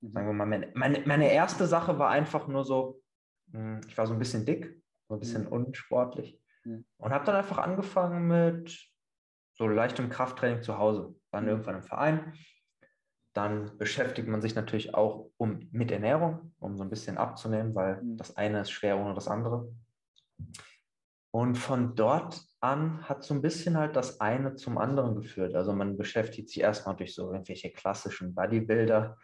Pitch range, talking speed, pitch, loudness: 105-145 Hz, 170 wpm, 115 Hz, -31 LUFS